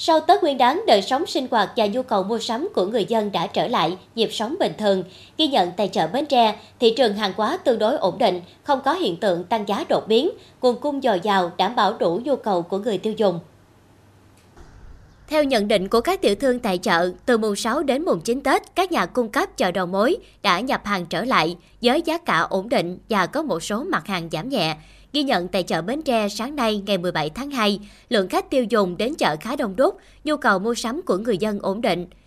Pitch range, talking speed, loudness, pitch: 190-265 Hz, 240 wpm, -21 LUFS, 220 Hz